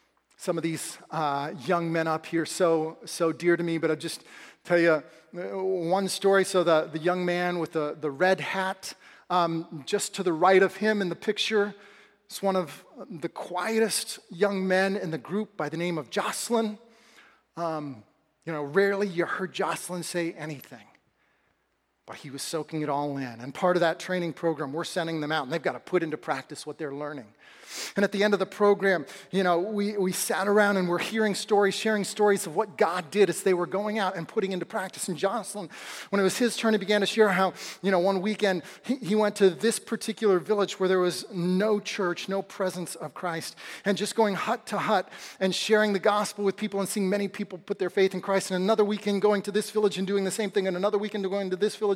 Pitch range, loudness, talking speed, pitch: 170-205 Hz, -27 LUFS, 225 wpm, 190 Hz